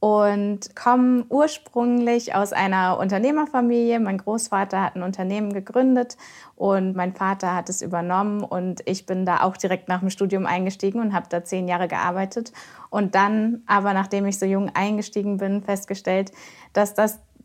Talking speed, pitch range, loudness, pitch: 160 wpm, 190-225 Hz, -22 LUFS, 200 Hz